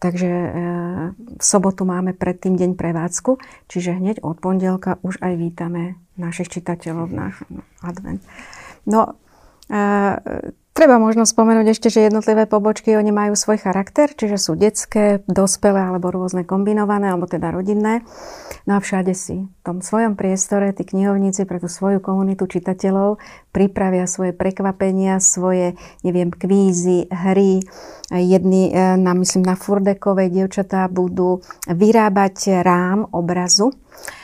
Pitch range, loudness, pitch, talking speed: 180-205 Hz, -17 LUFS, 190 Hz, 130 wpm